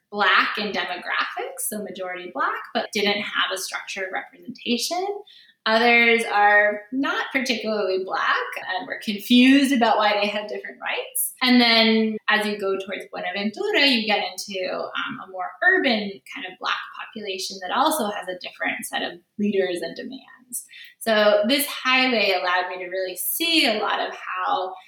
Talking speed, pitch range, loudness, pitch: 160 wpm, 195-255 Hz, -21 LUFS, 210 Hz